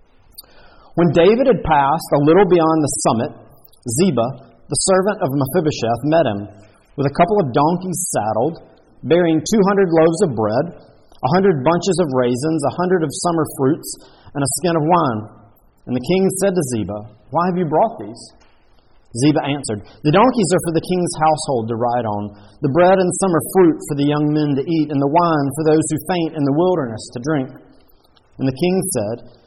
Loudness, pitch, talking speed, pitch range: -17 LUFS, 155 Hz, 190 wpm, 130-175 Hz